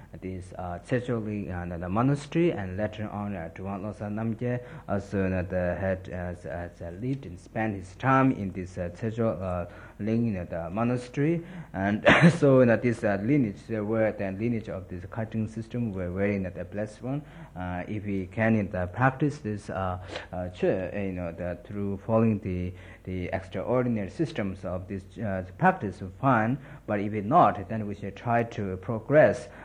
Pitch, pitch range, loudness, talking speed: 105 Hz, 95-115 Hz, -28 LUFS, 175 wpm